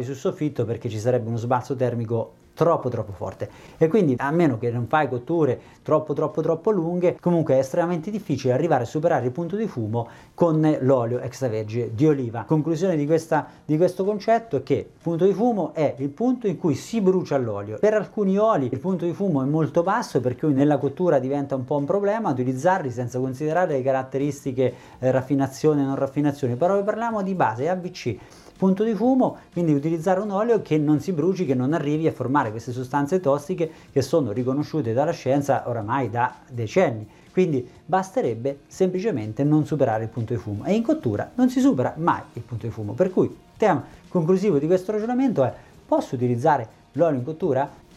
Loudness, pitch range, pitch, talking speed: -23 LUFS, 130-180 Hz, 150 Hz, 195 wpm